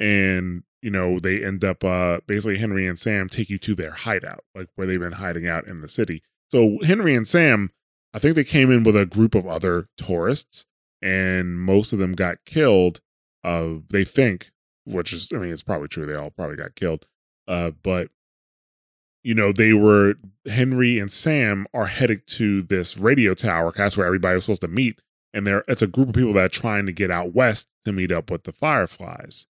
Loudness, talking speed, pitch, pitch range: -21 LUFS, 210 wpm, 100 Hz, 90-110 Hz